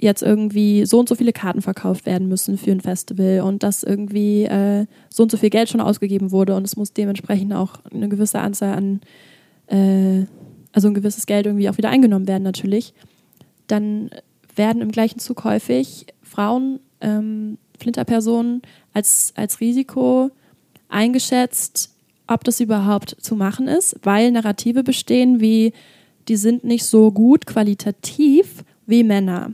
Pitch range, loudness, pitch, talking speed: 200-235 Hz, -18 LUFS, 210 Hz, 155 wpm